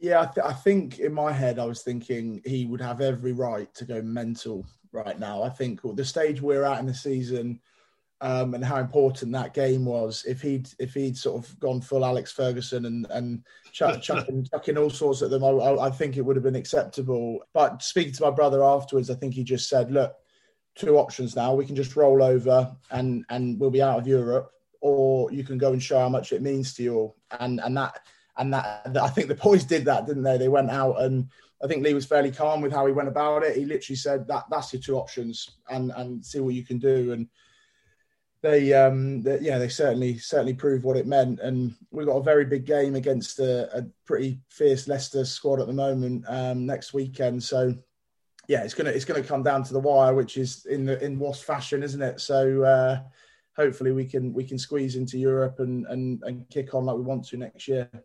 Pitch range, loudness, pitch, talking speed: 125-140 Hz, -25 LUFS, 130 Hz, 225 wpm